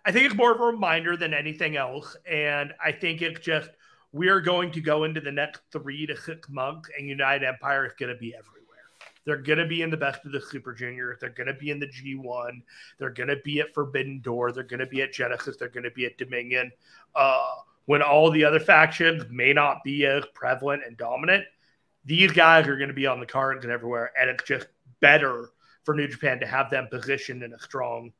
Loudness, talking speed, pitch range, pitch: -24 LUFS, 230 wpm, 130-155 Hz, 140 Hz